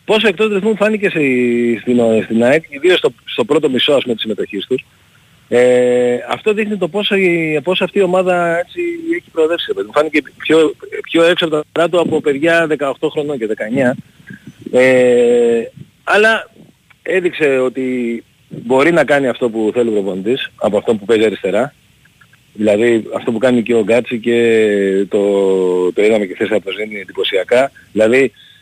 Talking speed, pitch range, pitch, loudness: 170 wpm, 120-185 Hz, 145 Hz, -14 LUFS